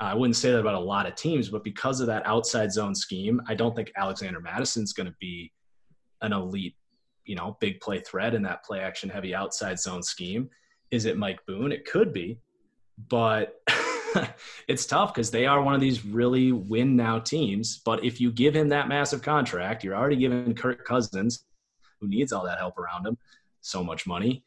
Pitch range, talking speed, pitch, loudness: 105-130 Hz, 200 wpm, 115 Hz, -27 LUFS